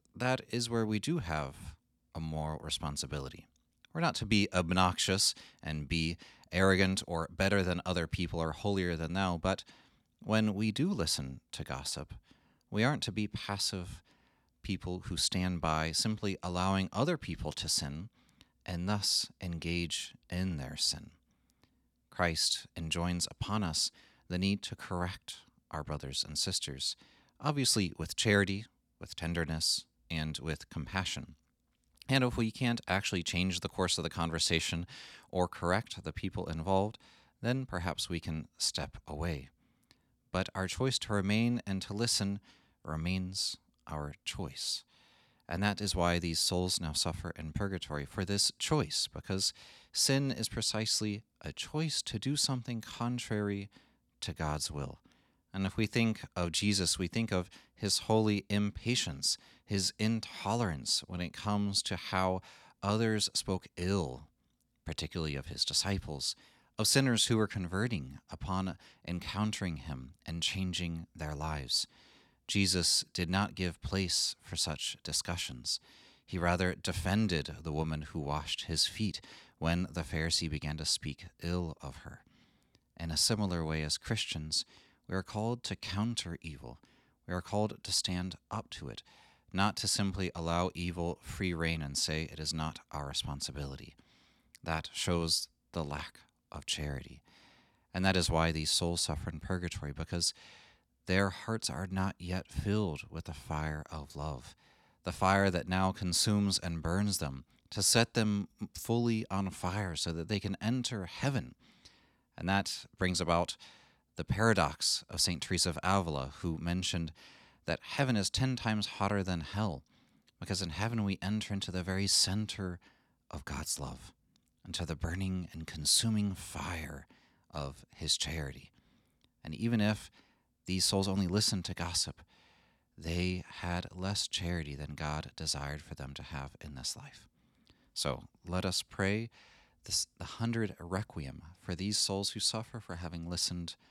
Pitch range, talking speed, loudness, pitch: 80-100 Hz, 150 wpm, -34 LUFS, 90 Hz